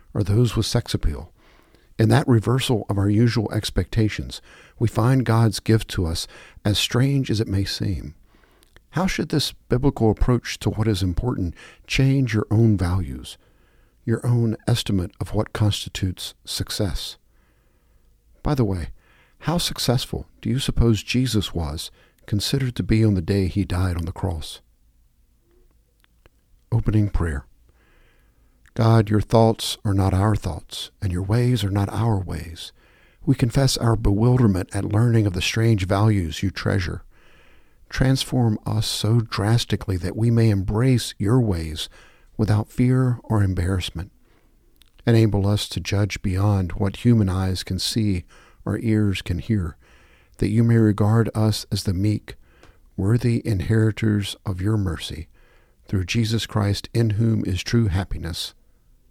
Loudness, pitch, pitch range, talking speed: -22 LUFS, 105 Hz, 95-115 Hz, 145 wpm